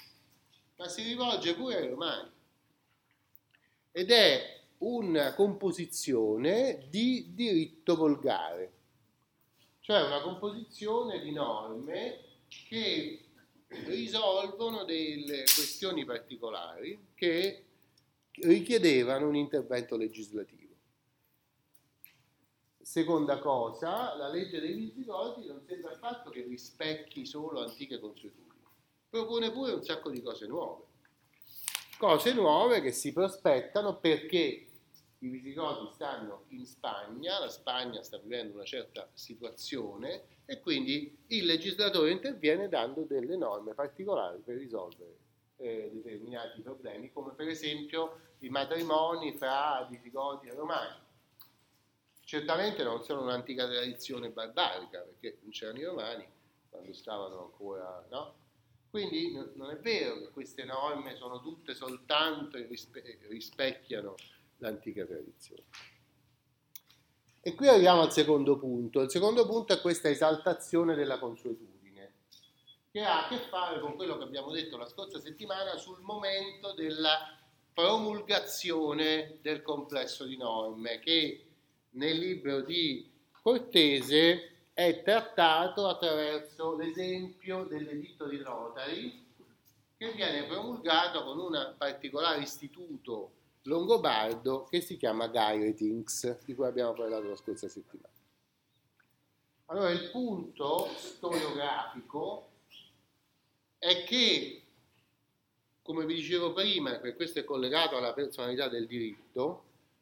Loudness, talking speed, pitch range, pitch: -32 LUFS, 110 wpm, 135-195 Hz, 155 Hz